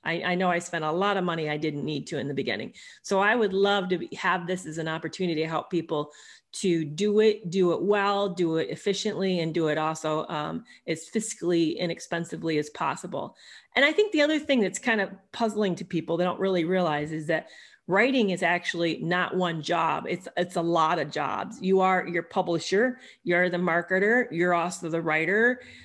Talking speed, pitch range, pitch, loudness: 205 wpm, 165-200 Hz, 175 Hz, -26 LUFS